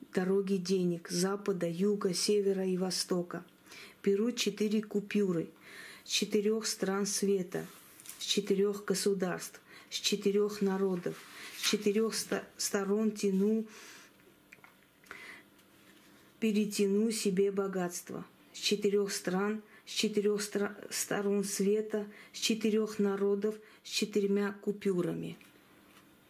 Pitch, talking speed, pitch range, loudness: 205 Hz, 90 wpm, 195-210 Hz, -32 LUFS